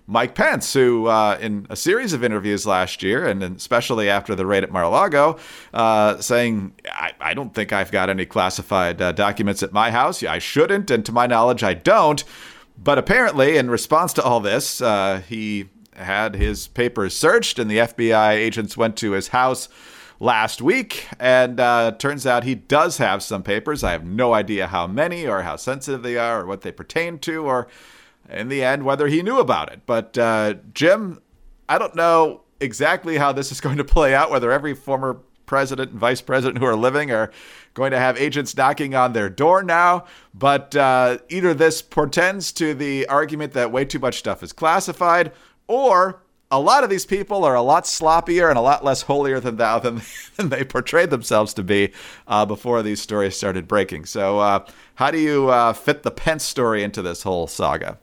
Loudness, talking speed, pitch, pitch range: -19 LUFS, 200 wpm, 125 Hz, 105-145 Hz